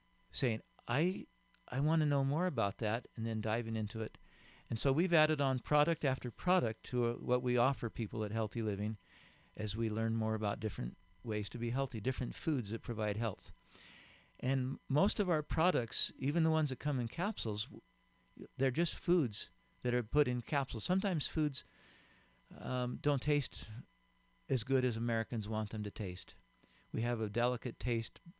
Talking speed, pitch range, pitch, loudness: 175 wpm, 110-145 Hz, 120 Hz, -36 LUFS